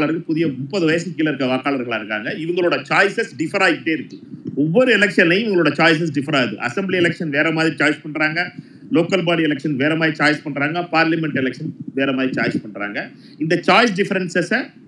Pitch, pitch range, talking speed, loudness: 160 Hz, 150-180 Hz, 165 wpm, -18 LUFS